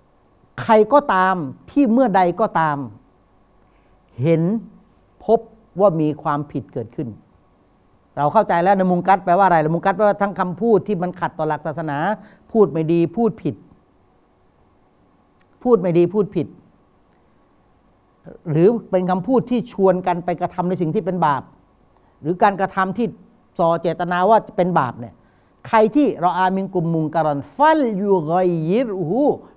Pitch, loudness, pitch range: 180 Hz, -19 LUFS, 150-205 Hz